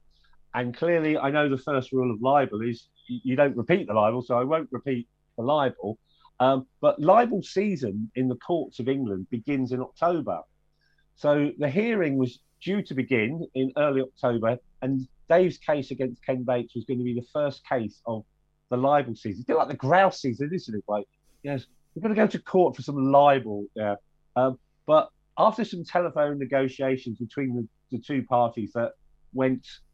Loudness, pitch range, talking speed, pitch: -26 LUFS, 125-155 Hz, 185 wpm, 135 Hz